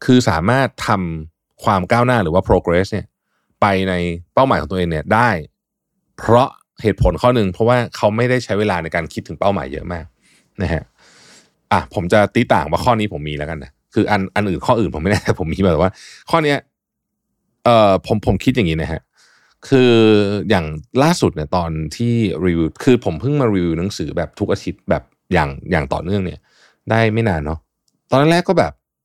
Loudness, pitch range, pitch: -17 LUFS, 85-115 Hz, 100 Hz